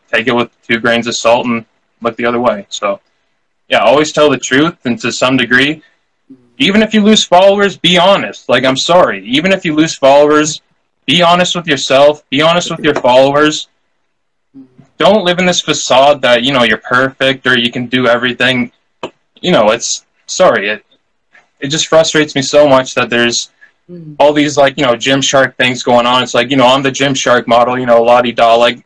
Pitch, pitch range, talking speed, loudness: 135 Hz, 125-155 Hz, 205 wpm, -10 LUFS